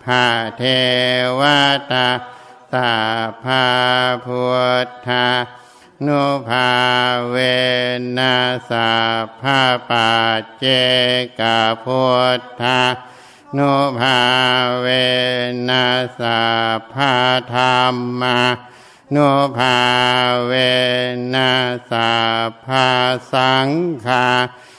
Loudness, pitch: -15 LUFS, 125 Hz